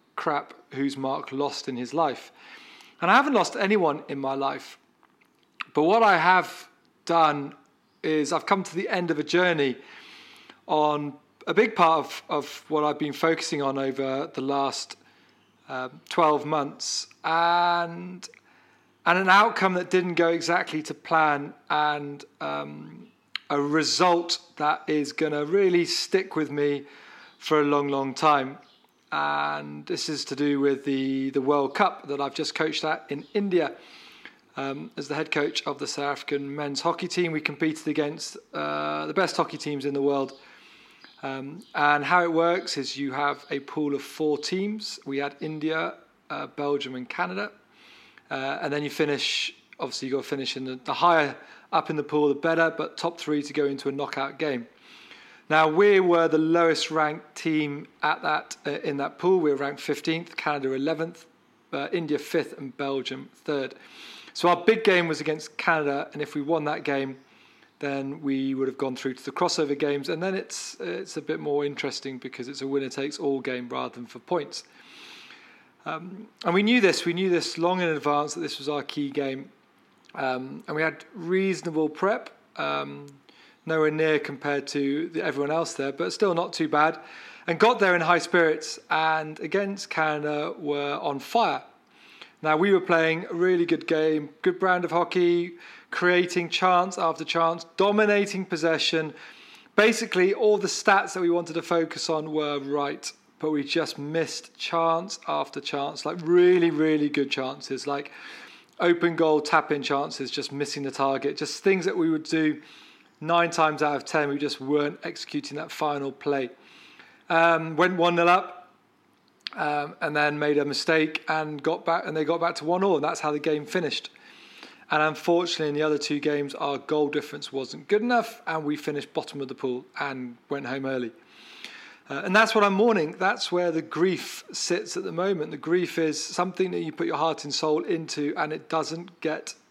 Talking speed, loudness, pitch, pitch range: 185 wpm, -26 LUFS, 155 Hz, 145-170 Hz